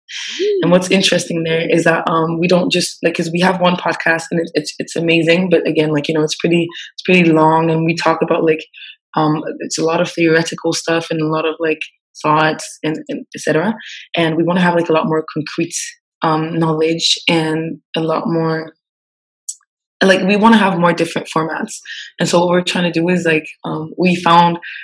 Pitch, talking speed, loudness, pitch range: 165 Hz, 215 wpm, -15 LUFS, 160-175 Hz